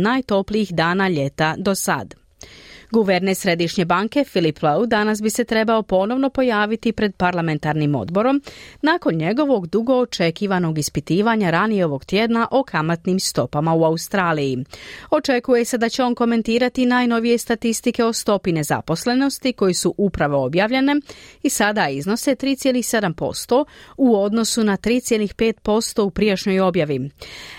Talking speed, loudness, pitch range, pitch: 125 wpm, -19 LUFS, 175-240 Hz, 210 Hz